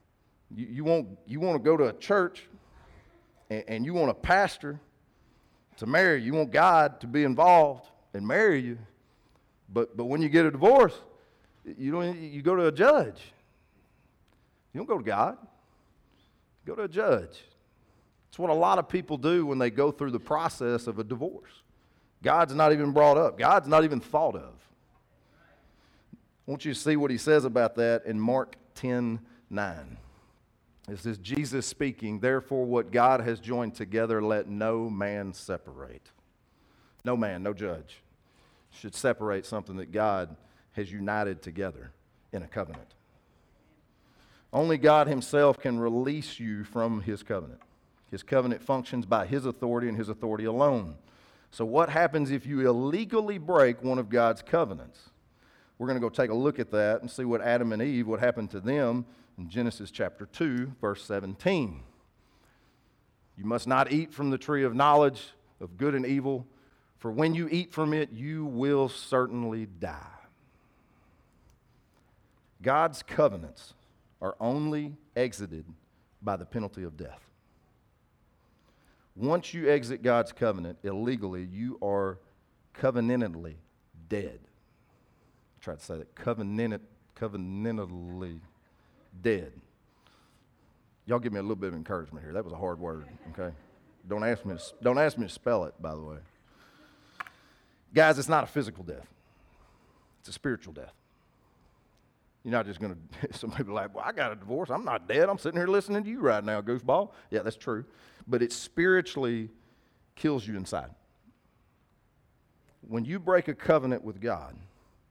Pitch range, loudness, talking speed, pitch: 105-145 Hz, -28 LUFS, 160 wpm, 120 Hz